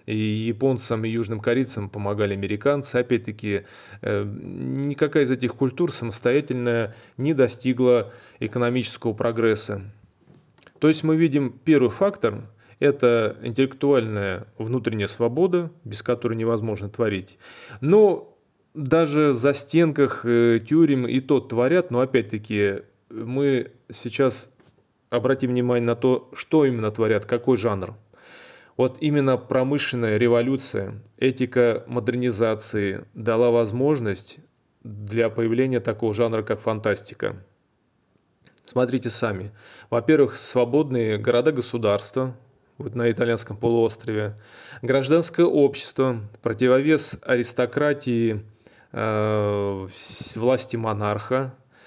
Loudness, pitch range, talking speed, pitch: -22 LUFS, 110-135 Hz, 95 wpm, 120 Hz